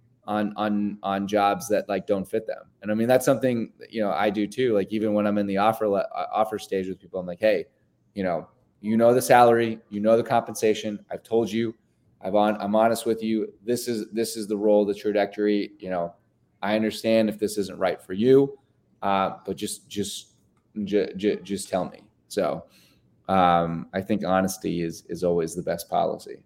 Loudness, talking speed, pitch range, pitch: -25 LUFS, 205 wpm, 100-110 Hz, 105 Hz